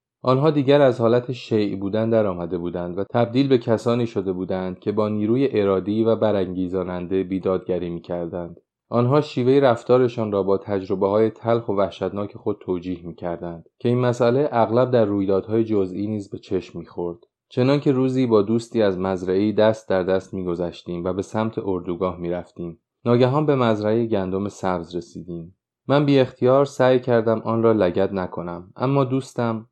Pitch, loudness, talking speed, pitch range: 105 Hz, -21 LUFS, 170 wpm, 95-120 Hz